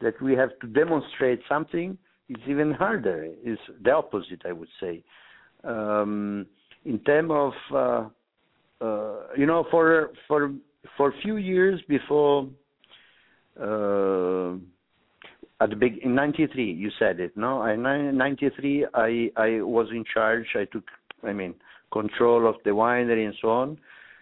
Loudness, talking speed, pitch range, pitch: -25 LUFS, 145 wpm, 110-145 Hz, 130 Hz